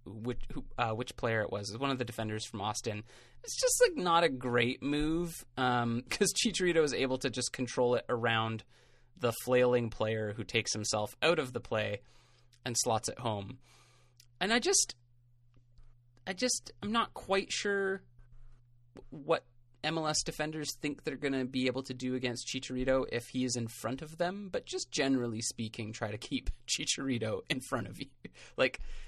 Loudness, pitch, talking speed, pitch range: -33 LUFS, 125 Hz, 180 wpm, 115-145 Hz